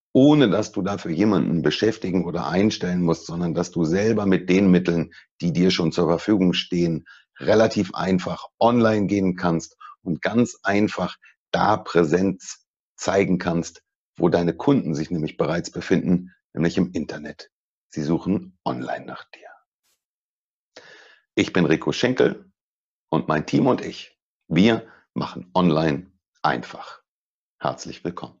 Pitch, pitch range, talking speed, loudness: 90 Hz, 85-100 Hz, 135 wpm, -22 LUFS